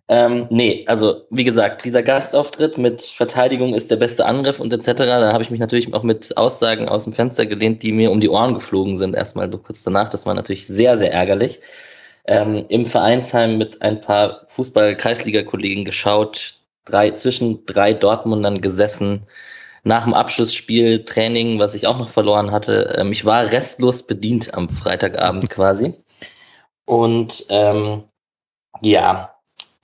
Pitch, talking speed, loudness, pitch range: 110 Hz, 155 wpm, -17 LUFS, 105-120 Hz